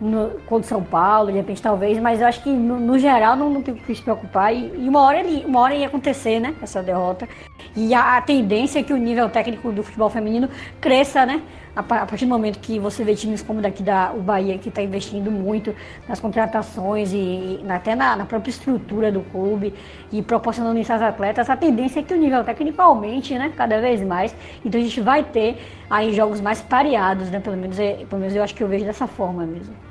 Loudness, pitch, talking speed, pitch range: -20 LUFS, 225 Hz, 230 wpm, 205-250 Hz